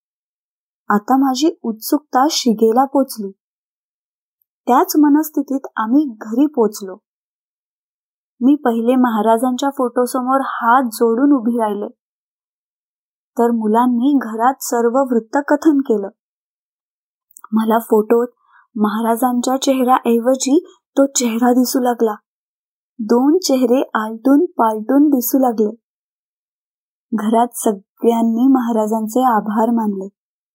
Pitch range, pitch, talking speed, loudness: 225-270 Hz, 245 Hz, 90 wpm, -16 LUFS